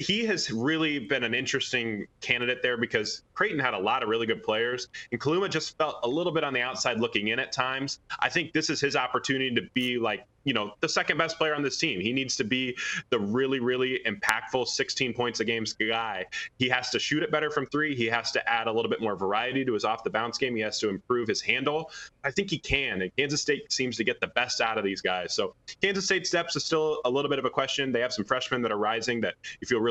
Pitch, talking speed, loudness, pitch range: 135 Hz, 260 wpm, -28 LUFS, 120-155 Hz